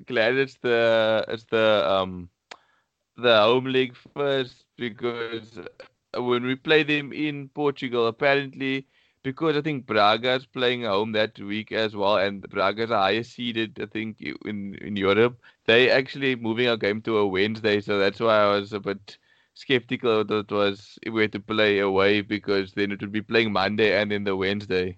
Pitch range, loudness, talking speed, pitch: 100-125 Hz, -24 LUFS, 180 wpm, 110 Hz